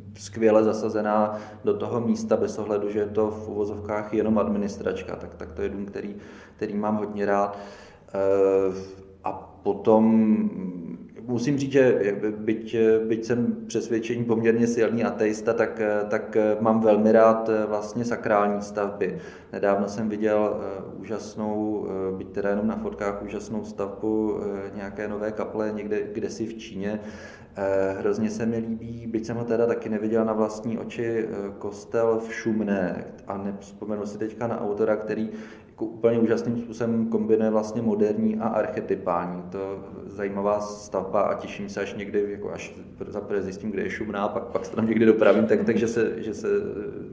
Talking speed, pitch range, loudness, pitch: 155 wpm, 100-110 Hz, -25 LUFS, 105 Hz